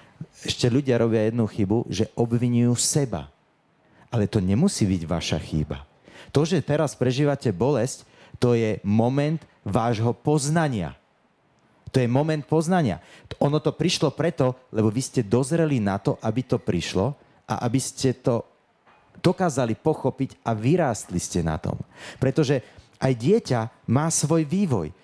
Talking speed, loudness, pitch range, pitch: 140 wpm, -24 LUFS, 110-145 Hz, 125 Hz